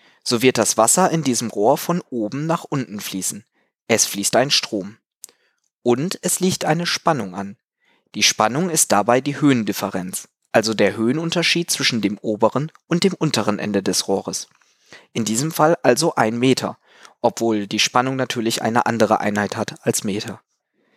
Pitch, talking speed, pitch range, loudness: 120 Hz, 160 wpm, 105-155 Hz, -19 LUFS